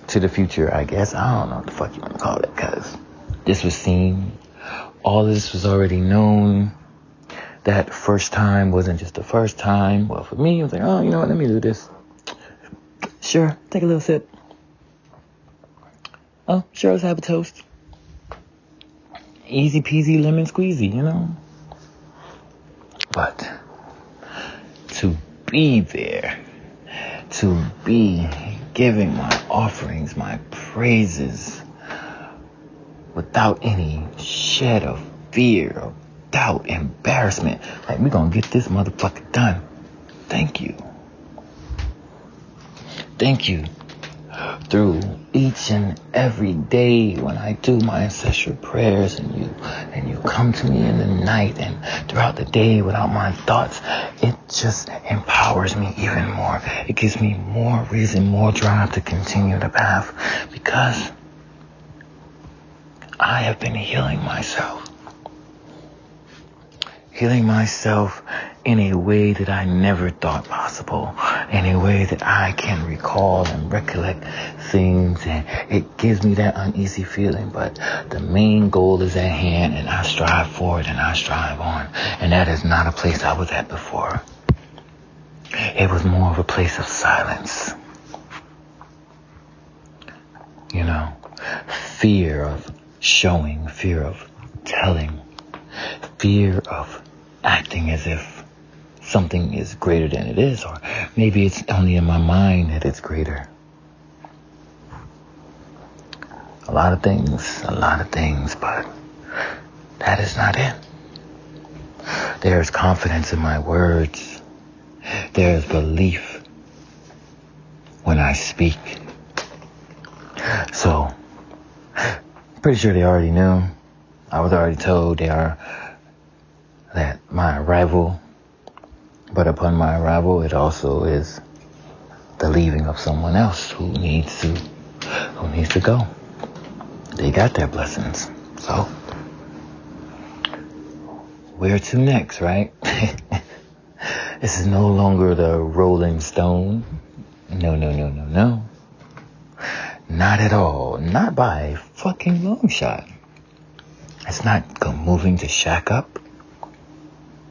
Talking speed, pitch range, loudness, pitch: 125 wpm, 80-105 Hz, -20 LUFS, 90 Hz